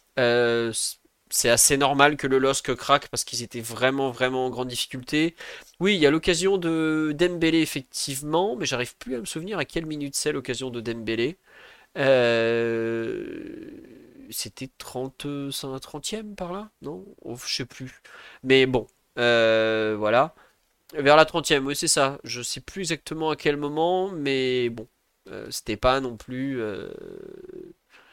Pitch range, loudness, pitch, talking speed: 125-165 Hz, -24 LUFS, 140 Hz, 160 wpm